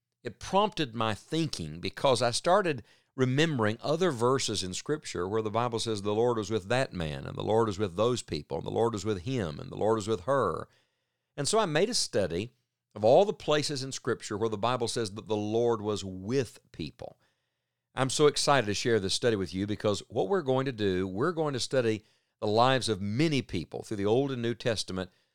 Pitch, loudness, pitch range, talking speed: 115 Hz, -29 LUFS, 105-135 Hz, 220 wpm